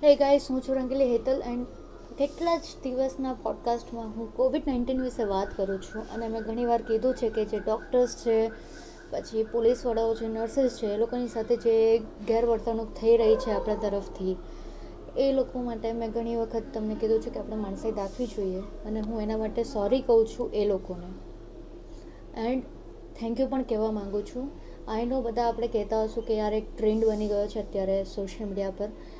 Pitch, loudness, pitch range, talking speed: 230 Hz, -28 LUFS, 215-250 Hz, 180 wpm